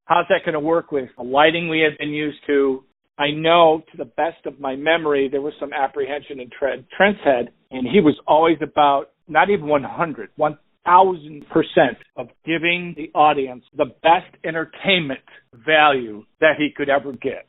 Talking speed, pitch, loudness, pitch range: 175 wpm, 150 Hz, -19 LUFS, 140-165 Hz